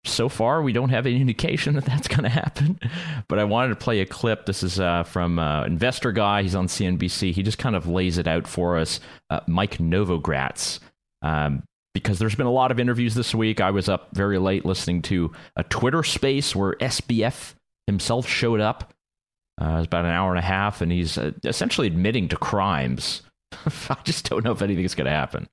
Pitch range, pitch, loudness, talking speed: 85-120 Hz, 100 Hz, -23 LUFS, 215 wpm